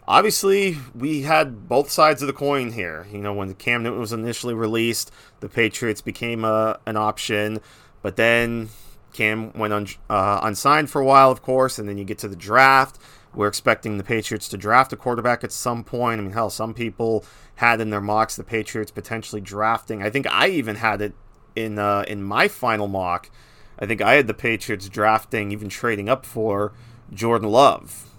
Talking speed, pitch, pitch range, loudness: 195 wpm, 115 Hz, 105-125 Hz, -21 LUFS